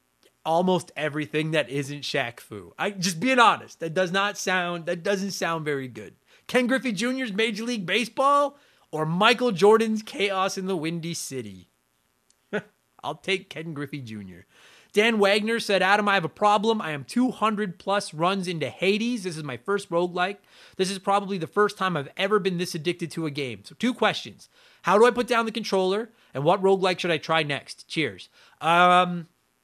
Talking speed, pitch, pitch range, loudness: 185 wpm, 190 Hz, 160-210 Hz, -24 LUFS